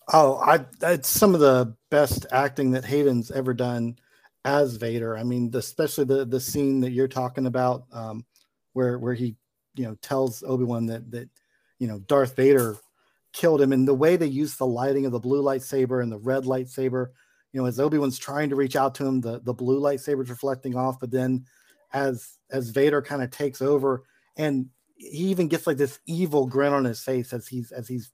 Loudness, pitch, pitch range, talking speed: -24 LUFS, 130 Hz, 125-140 Hz, 205 wpm